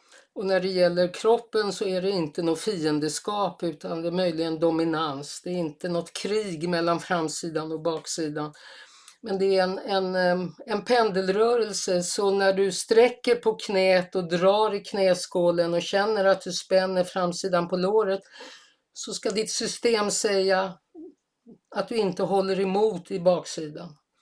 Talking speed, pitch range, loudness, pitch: 155 wpm, 175-205 Hz, -25 LUFS, 190 Hz